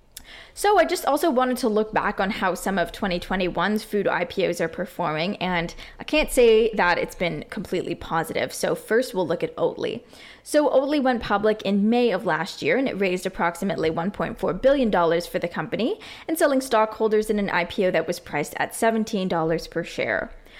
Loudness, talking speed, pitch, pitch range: -23 LUFS, 185 wpm, 215 Hz, 180-255 Hz